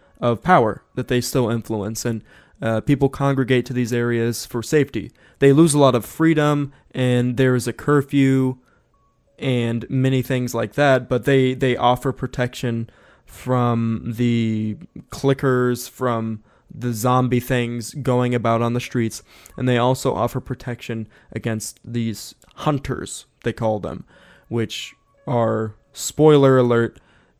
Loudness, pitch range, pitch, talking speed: -20 LUFS, 115-130 Hz, 125 Hz, 140 wpm